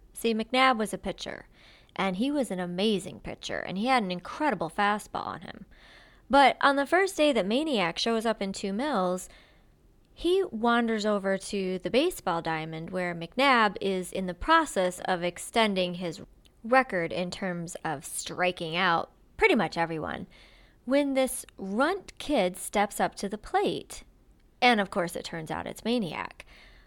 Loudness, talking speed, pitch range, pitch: -28 LUFS, 165 wpm, 180-260 Hz, 205 Hz